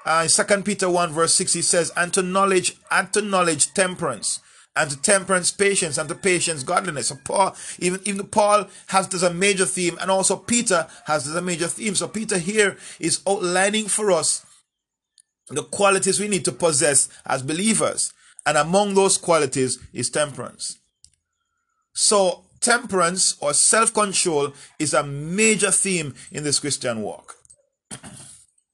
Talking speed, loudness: 155 wpm, -20 LUFS